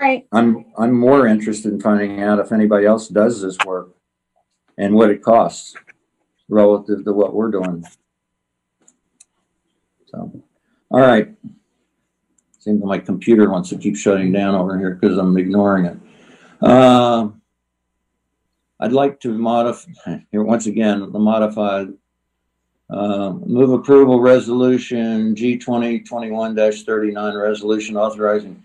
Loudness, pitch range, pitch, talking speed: -16 LUFS, 100-115 Hz, 105 Hz, 120 wpm